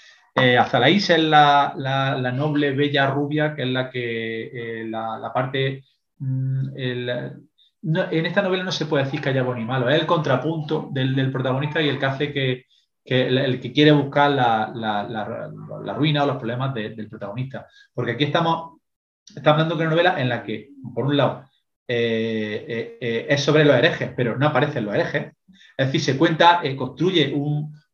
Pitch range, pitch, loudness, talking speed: 125-150 Hz, 135 Hz, -21 LUFS, 205 wpm